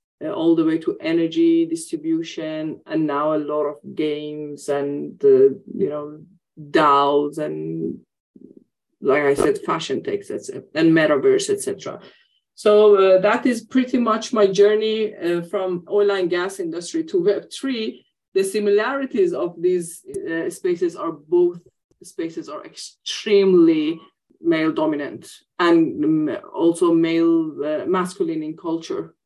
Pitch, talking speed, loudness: 310 Hz, 135 wpm, -20 LUFS